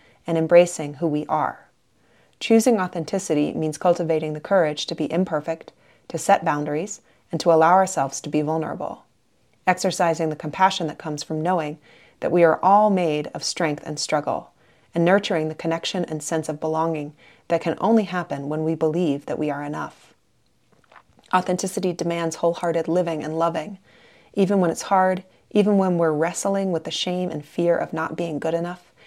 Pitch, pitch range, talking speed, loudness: 165 Hz, 155-180 Hz, 170 wpm, -22 LUFS